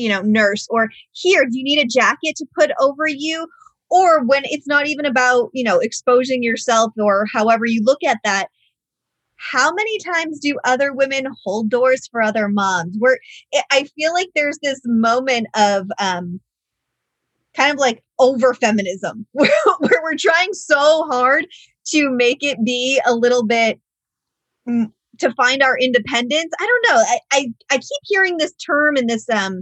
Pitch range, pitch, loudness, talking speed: 230-300 Hz, 260 Hz, -17 LUFS, 170 wpm